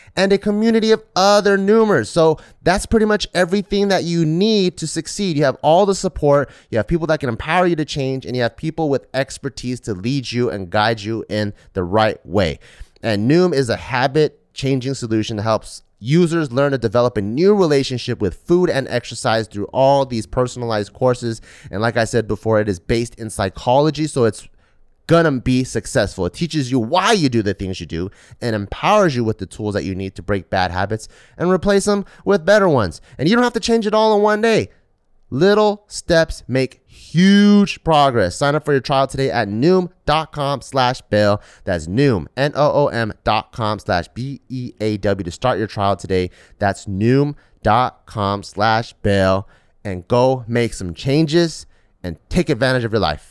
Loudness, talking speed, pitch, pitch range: -18 LUFS, 190 wpm, 125 Hz, 105-160 Hz